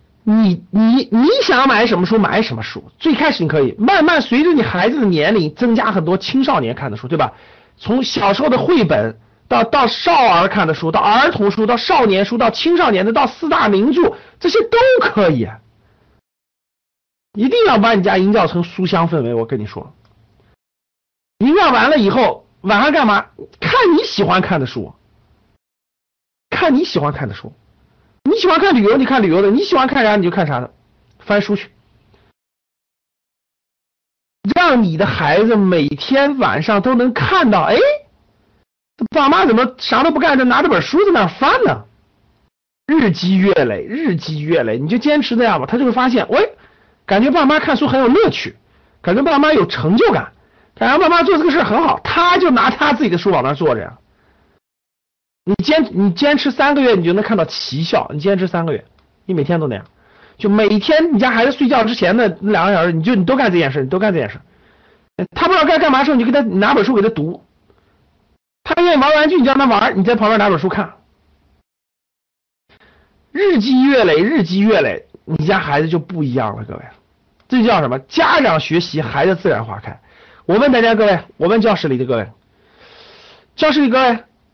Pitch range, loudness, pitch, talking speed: 180-280 Hz, -14 LUFS, 220 Hz, 275 characters per minute